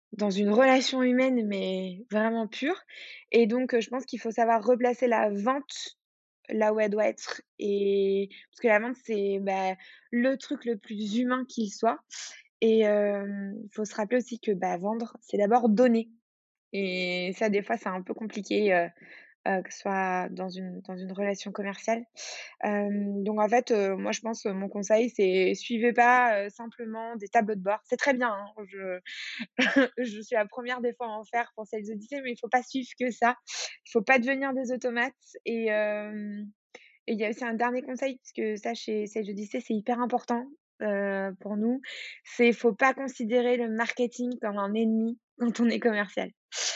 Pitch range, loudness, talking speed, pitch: 205-245 Hz, -28 LUFS, 200 wpm, 225 Hz